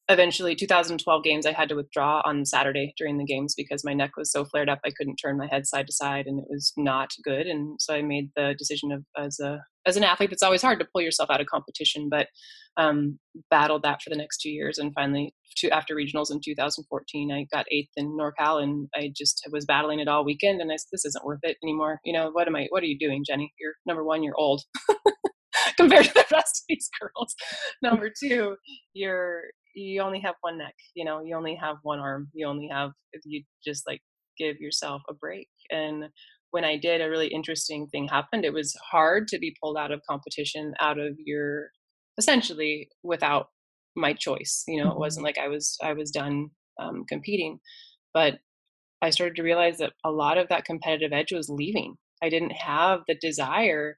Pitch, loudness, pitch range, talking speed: 150 Hz, -26 LUFS, 145-170 Hz, 220 wpm